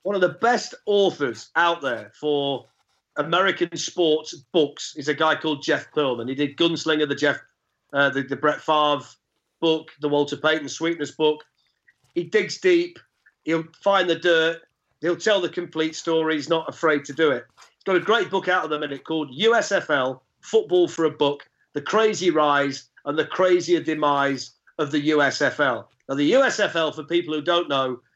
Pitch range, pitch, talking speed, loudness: 145-175 Hz, 155 Hz, 180 wpm, -22 LUFS